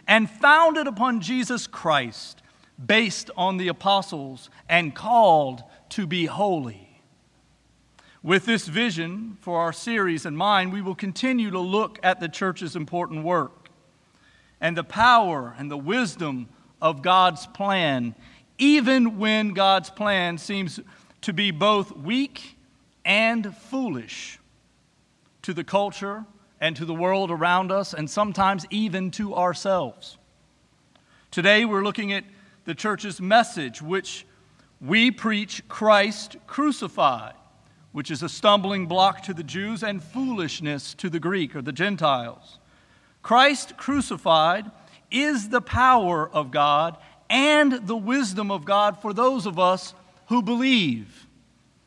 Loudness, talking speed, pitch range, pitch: -22 LUFS, 130 wpm, 170-220 Hz, 195 Hz